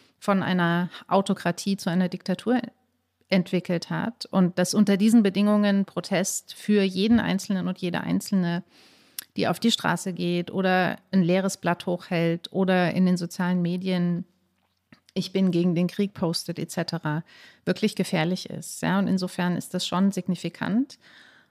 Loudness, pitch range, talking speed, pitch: -25 LUFS, 175-195 Hz, 145 wpm, 185 Hz